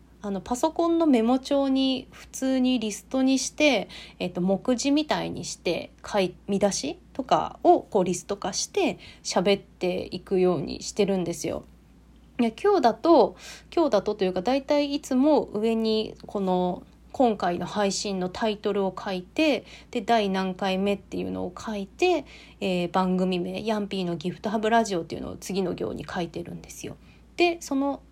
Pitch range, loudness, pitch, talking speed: 185-265 Hz, -26 LUFS, 210 Hz, 320 characters per minute